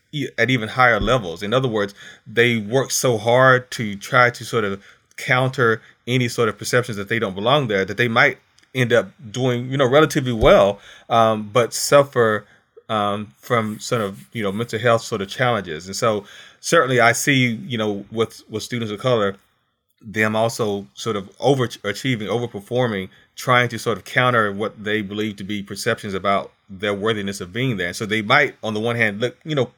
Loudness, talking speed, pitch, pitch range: -20 LUFS, 195 wpm, 115 Hz, 105-125 Hz